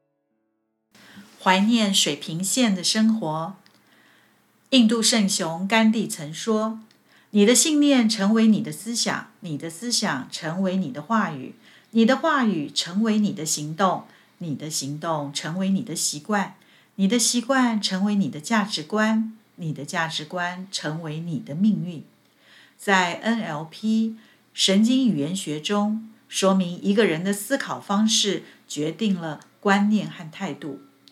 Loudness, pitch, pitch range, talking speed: -23 LUFS, 195 Hz, 165-220 Hz, 205 characters per minute